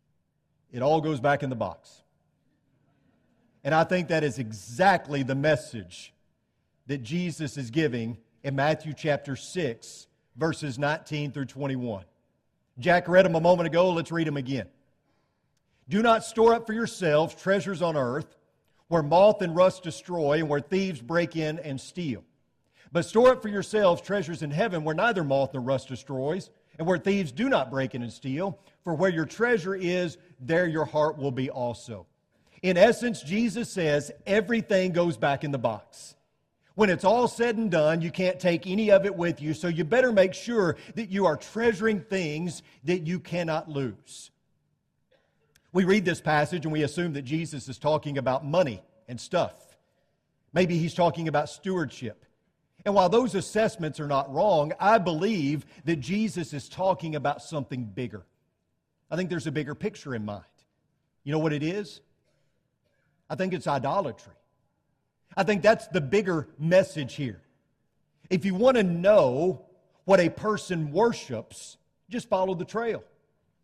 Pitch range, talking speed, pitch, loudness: 140-185 Hz, 165 wpm, 160 Hz, -26 LUFS